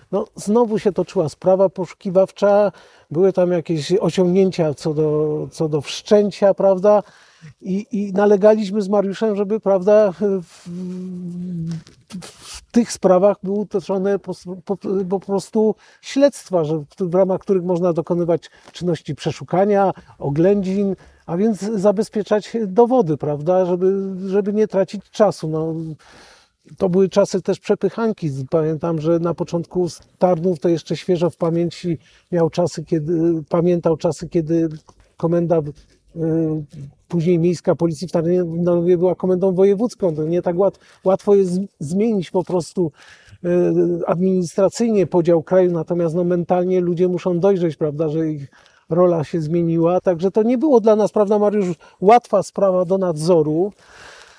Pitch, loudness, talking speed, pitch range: 180 Hz, -18 LUFS, 135 wpm, 170-195 Hz